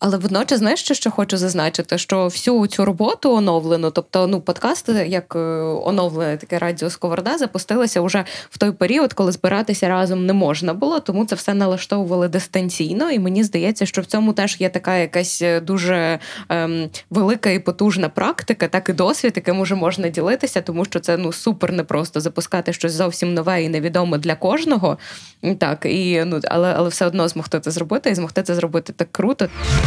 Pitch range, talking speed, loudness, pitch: 170-200 Hz, 185 wpm, -19 LUFS, 185 Hz